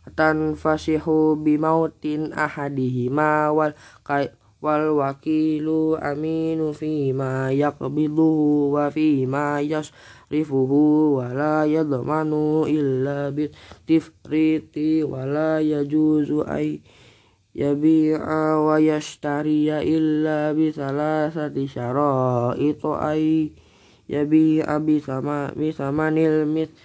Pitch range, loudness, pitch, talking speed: 145-155 Hz, -22 LUFS, 150 Hz, 65 wpm